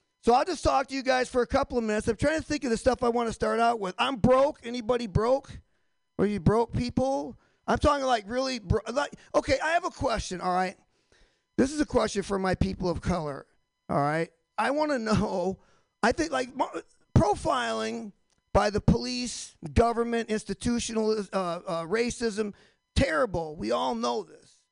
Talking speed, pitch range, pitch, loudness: 190 wpm, 210-260 Hz, 235 Hz, -28 LUFS